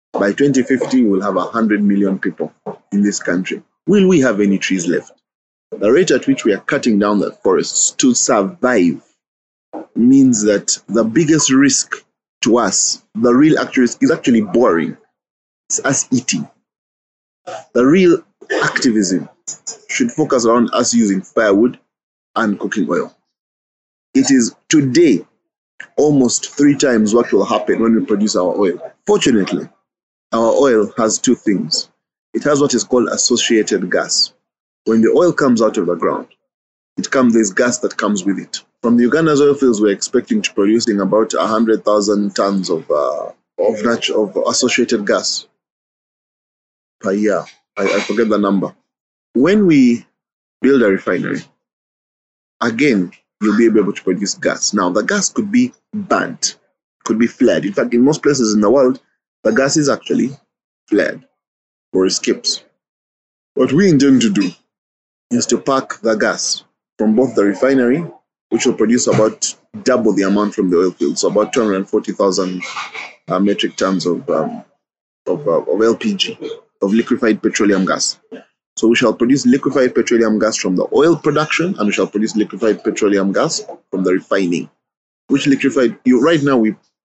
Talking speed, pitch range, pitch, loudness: 160 wpm, 105-170 Hz, 120 Hz, -15 LUFS